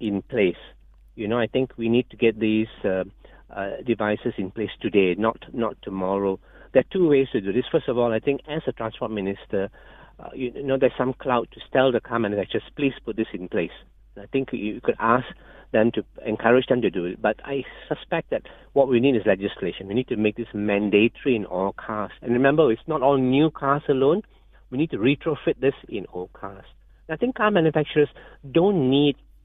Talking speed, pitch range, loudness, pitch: 210 wpm, 105-135 Hz, -23 LUFS, 120 Hz